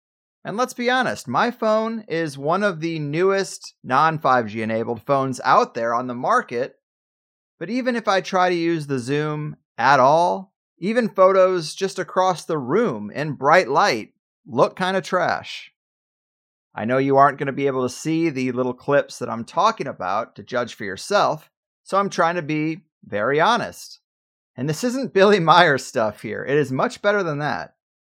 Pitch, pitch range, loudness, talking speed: 160 Hz, 130-195 Hz, -20 LUFS, 180 wpm